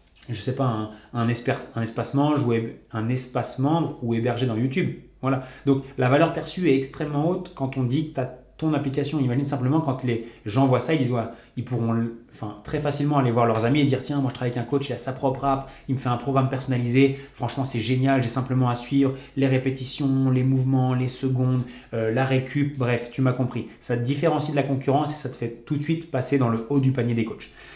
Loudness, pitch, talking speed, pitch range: -24 LUFS, 130 Hz, 245 wpm, 120-140 Hz